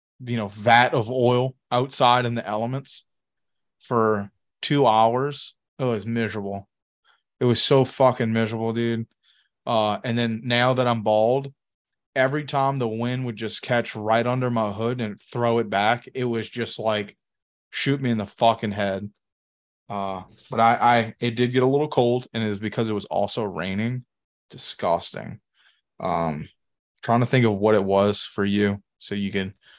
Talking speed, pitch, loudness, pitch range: 170 wpm, 115 Hz, -23 LUFS, 105-125 Hz